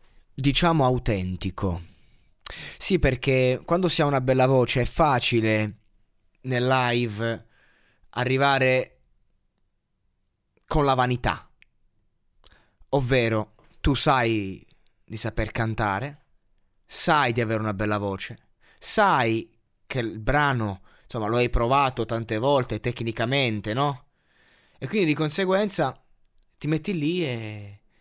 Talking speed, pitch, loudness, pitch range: 105 wpm, 120 Hz, -24 LUFS, 105-135 Hz